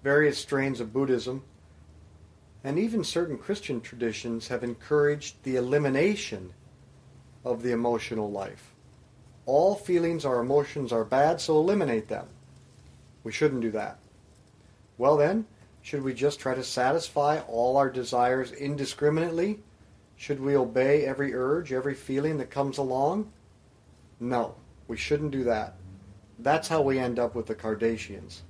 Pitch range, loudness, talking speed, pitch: 110-145 Hz, -28 LUFS, 135 wpm, 130 Hz